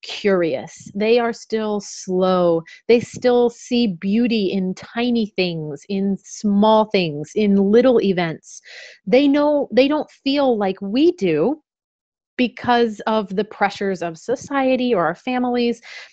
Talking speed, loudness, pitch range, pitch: 130 wpm, -19 LUFS, 195-245 Hz, 220 Hz